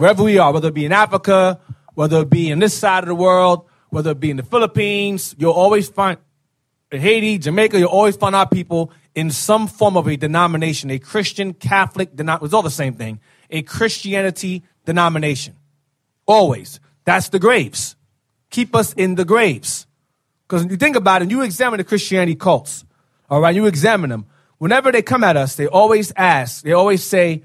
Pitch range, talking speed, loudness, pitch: 150-200 Hz, 190 wpm, -16 LUFS, 175 Hz